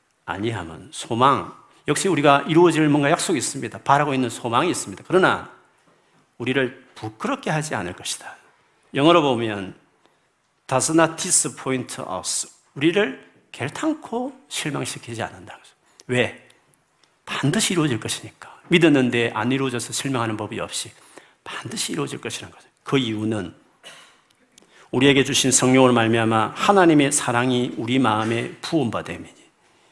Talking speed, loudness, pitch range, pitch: 340 characters per minute, -21 LUFS, 115-155 Hz, 130 Hz